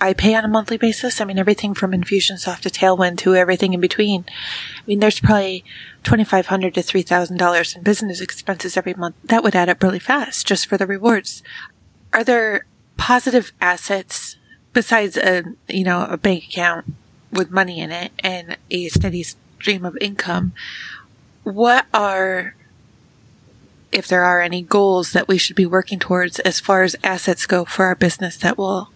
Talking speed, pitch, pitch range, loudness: 170 wpm, 190 Hz, 180-205 Hz, -18 LUFS